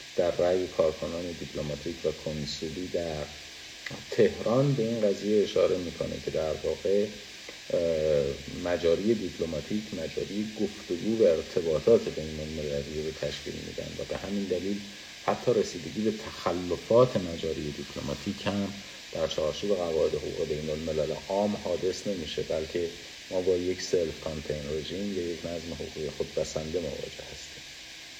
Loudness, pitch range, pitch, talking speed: -30 LUFS, 80-105 Hz, 90 Hz, 130 wpm